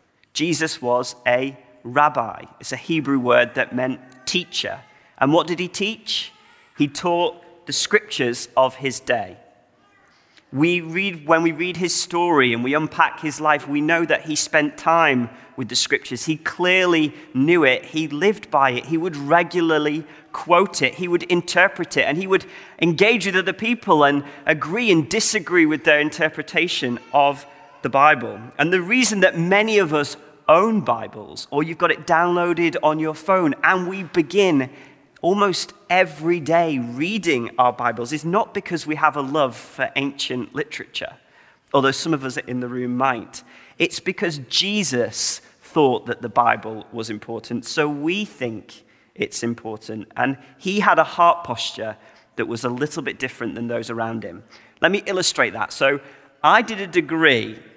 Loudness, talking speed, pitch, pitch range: -20 LUFS, 165 wpm, 155 Hz, 135-180 Hz